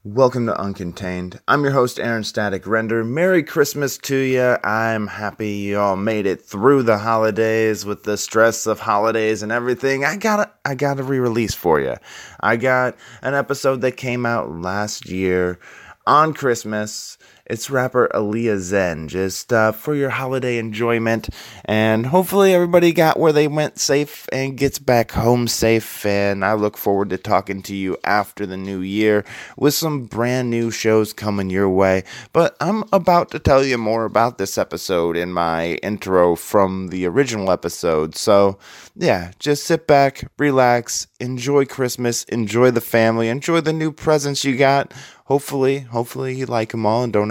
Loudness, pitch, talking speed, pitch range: -19 LUFS, 115 Hz, 170 wpm, 105-135 Hz